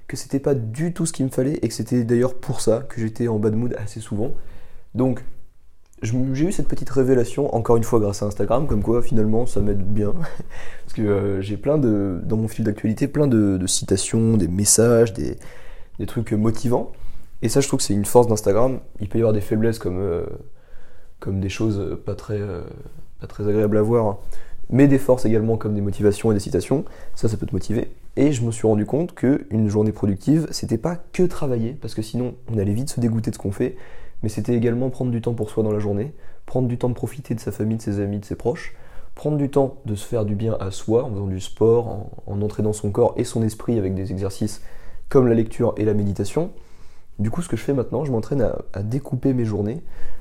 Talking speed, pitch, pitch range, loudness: 240 wpm, 110 Hz, 105-125 Hz, -22 LUFS